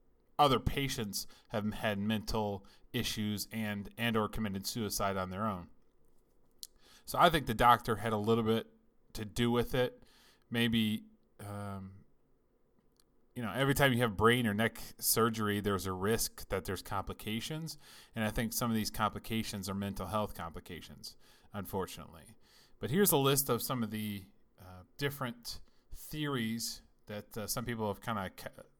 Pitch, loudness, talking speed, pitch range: 110 Hz, -34 LUFS, 160 wpm, 100-120 Hz